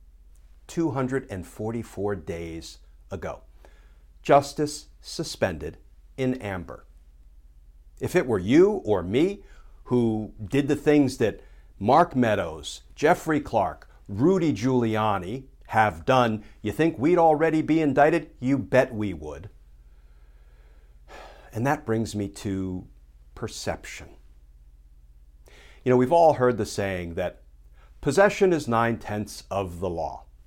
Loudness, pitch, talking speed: -24 LUFS, 100 Hz, 110 wpm